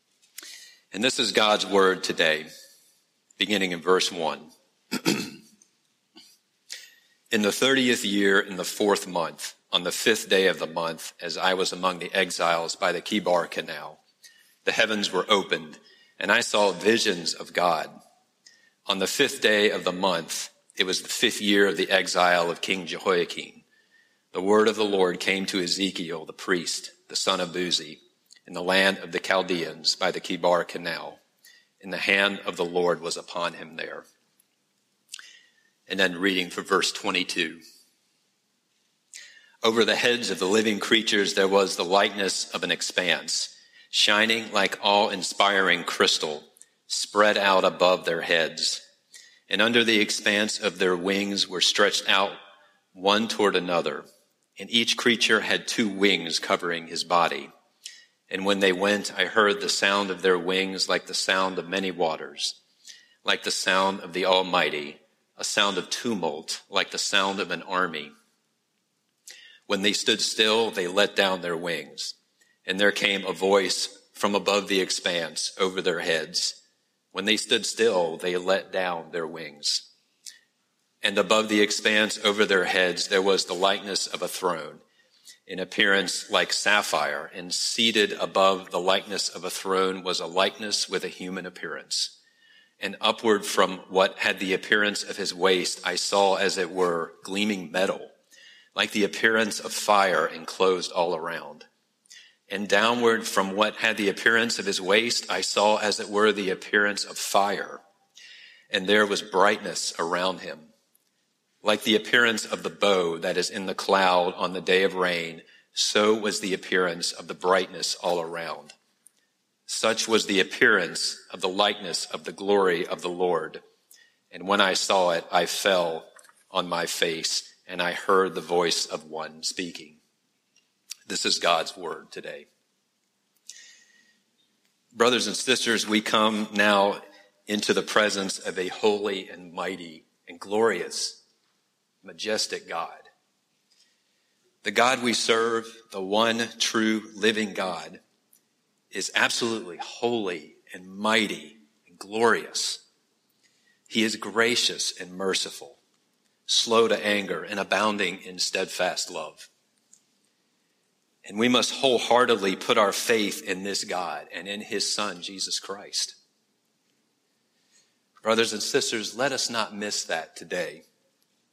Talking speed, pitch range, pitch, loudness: 150 wpm, 95-110 Hz, 100 Hz, -24 LUFS